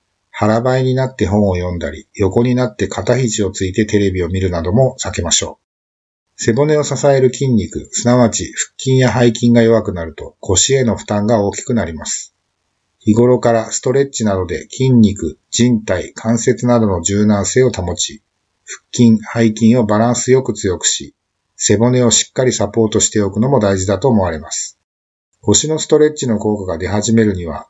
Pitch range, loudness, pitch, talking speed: 95-125 Hz, -14 LUFS, 110 Hz, 345 characters per minute